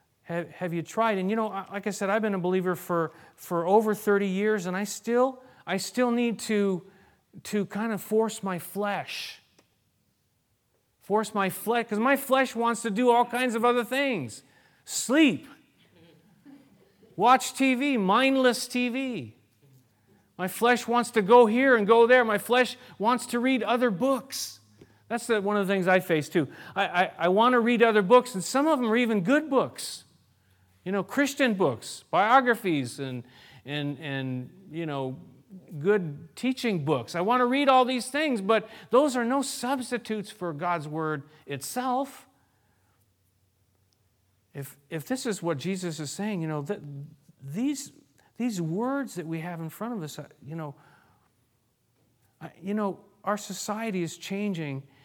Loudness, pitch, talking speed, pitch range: -26 LUFS, 205 Hz, 165 wpm, 160-240 Hz